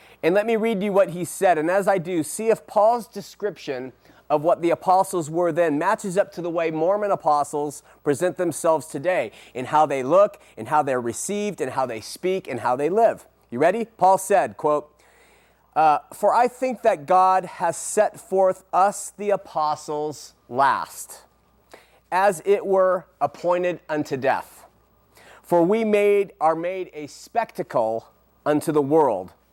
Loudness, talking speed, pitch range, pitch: -22 LUFS, 165 wpm, 150-200 Hz, 180 Hz